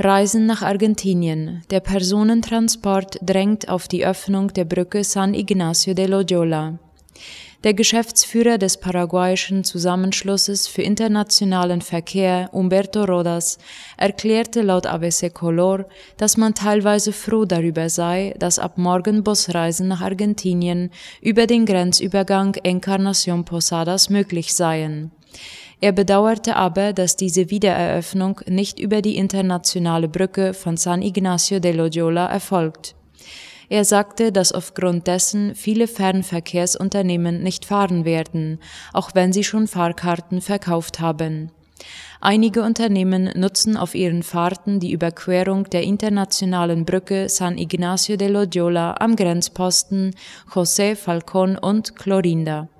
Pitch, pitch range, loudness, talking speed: 190 Hz, 175-200 Hz, -19 LUFS, 115 wpm